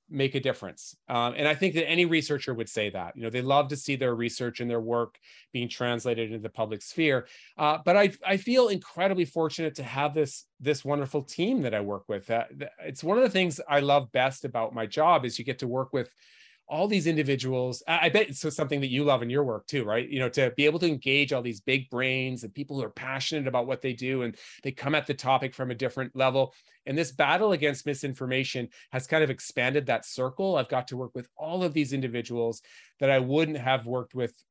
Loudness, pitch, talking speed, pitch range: -28 LUFS, 135 Hz, 240 wpm, 125-150 Hz